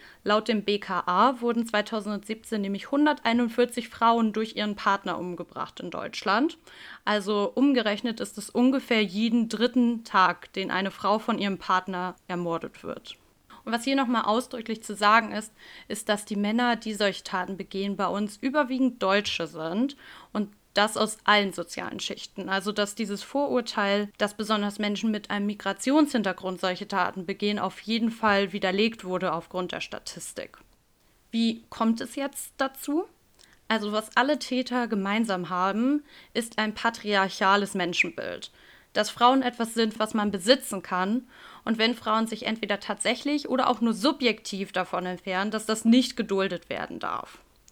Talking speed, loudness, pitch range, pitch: 150 wpm, -27 LUFS, 195-235 Hz, 215 Hz